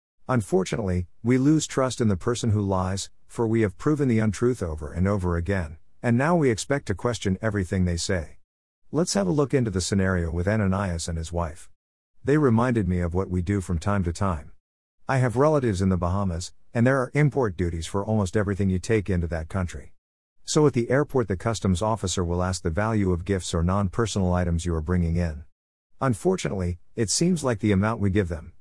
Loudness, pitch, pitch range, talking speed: -25 LUFS, 100 Hz, 90-120 Hz, 210 wpm